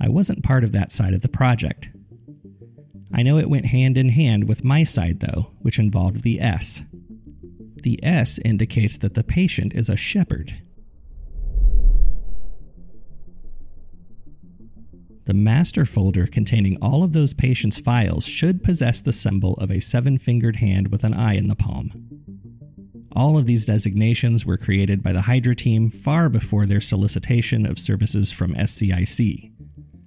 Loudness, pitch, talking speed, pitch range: -19 LUFS, 110 Hz, 150 wpm, 95-125 Hz